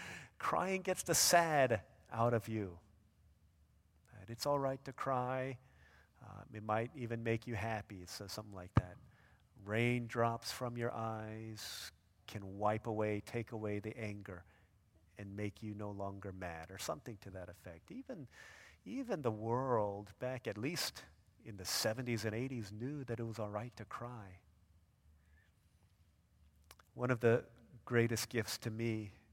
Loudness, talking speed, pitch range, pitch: -39 LUFS, 145 wpm, 95-120 Hz, 110 Hz